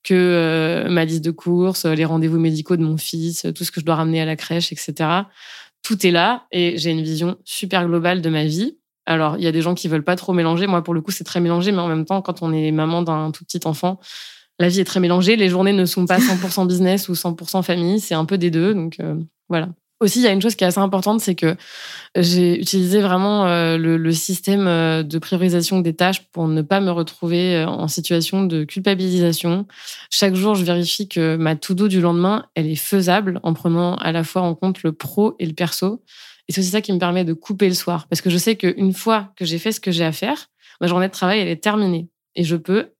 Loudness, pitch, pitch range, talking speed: -19 LUFS, 175 Hz, 165-190 Hz, 250 wpm